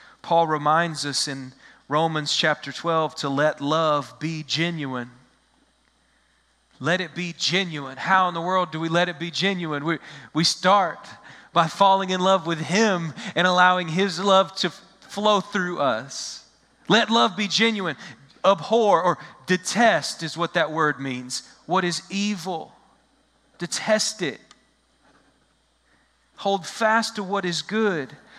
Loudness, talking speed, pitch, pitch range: -22 LUFS, 140 wpm, 175 Hz, 155-195 Hz